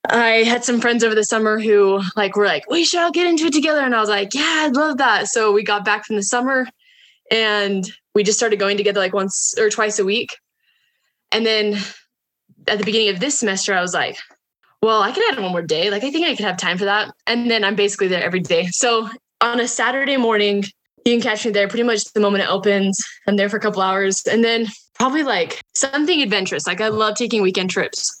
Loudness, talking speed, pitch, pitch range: -18 LUFS, 240 wpm, 220 Hz, 200-245 Hz